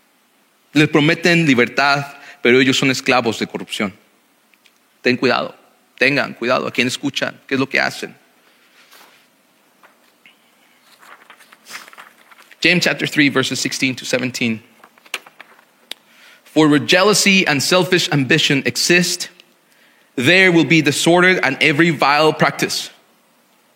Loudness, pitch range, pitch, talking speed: -15 LUFS, 135-175 Hz, 150 Hz, 110 wpm